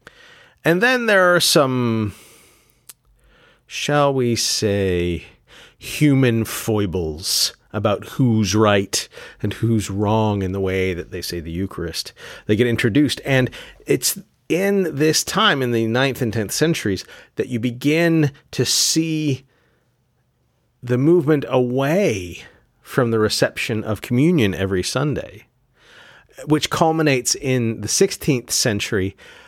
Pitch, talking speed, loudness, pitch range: 120 Hz, 120 wpm, -19 LUFS, 105-150 Hz